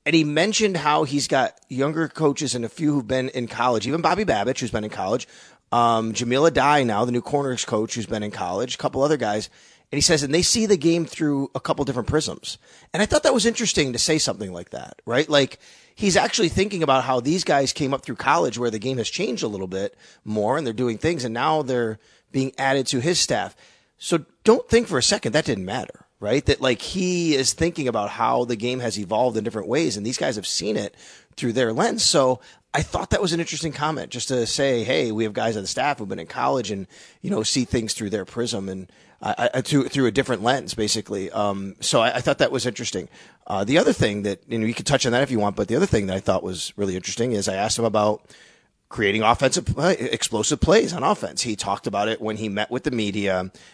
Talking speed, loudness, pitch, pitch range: 245 wpm, -22 LUFS, 130 Hz, 110-150 Hz